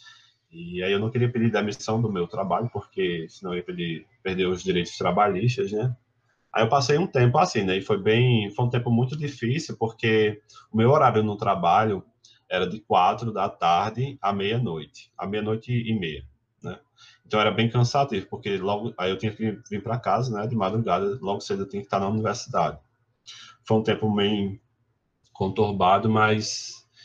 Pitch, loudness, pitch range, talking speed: 110 Hz, -24 LUFS, 100-120 Hz, 180 wpm